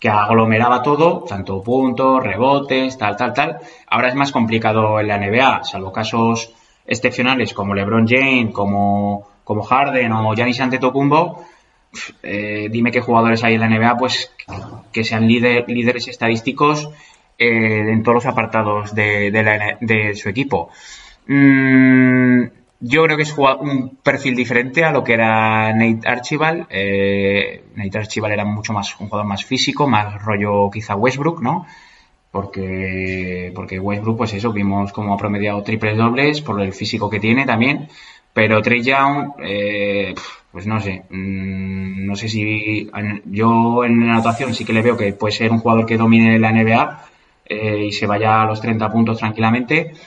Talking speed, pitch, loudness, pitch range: 165 wpm, 110 Hz, -16 LUFS, 105-125 Hz